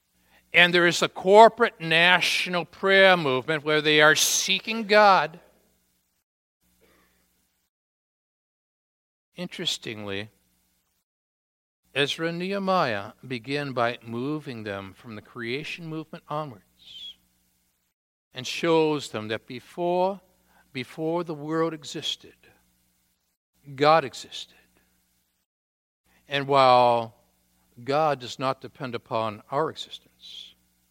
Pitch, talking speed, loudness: 130 Hz, 90 wpm, -23 LUFS